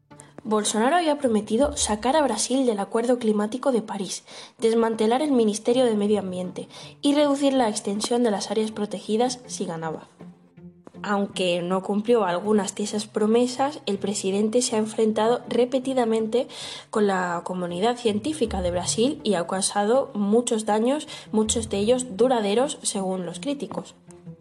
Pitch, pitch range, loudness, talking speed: 220 Hz, 200-245 Hz, -24 LUFS, 145 wpm